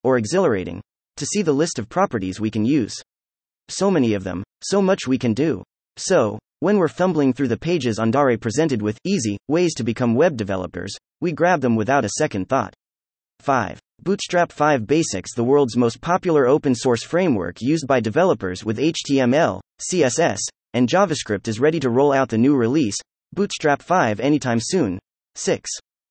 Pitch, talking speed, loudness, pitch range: 130 Hz, 170 wpm, -20 LUFS, 110-155 Hz